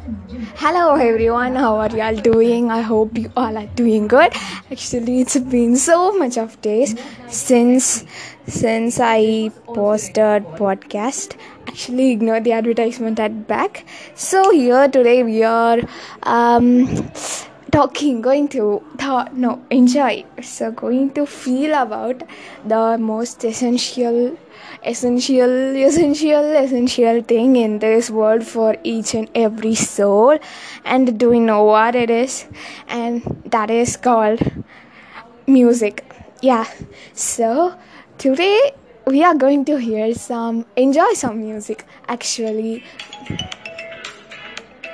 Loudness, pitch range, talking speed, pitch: -16 LUFS, 225-260 Hz, 120 wpm, 235 Hz